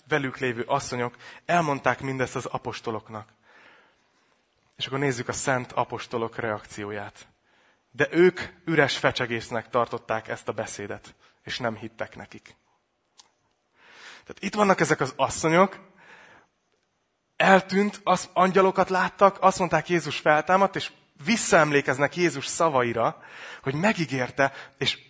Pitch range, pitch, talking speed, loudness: 120-175 Hz, 140 Hz, 110 wpm, -24 LUFS